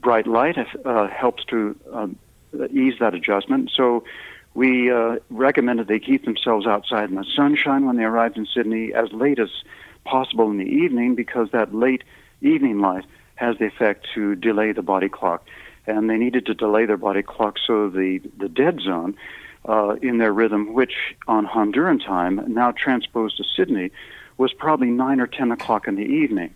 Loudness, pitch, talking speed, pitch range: -21 LUFS, 115 Hz, 180 wpm, 110-130 Hz